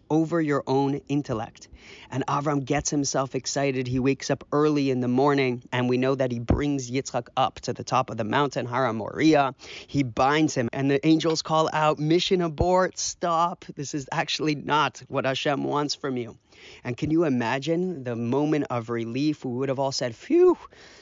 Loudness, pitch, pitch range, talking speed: -25 LUFS, 140 Hz, 125-155 Hz, 190 wpm